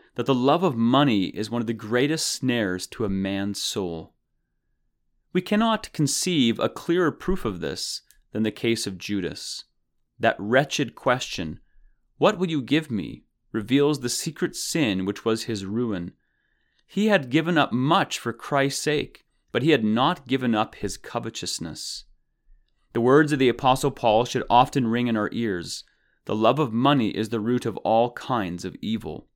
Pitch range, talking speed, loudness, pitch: 110-145 Hz, 170 wpm, -24 LUFS, 120 Hz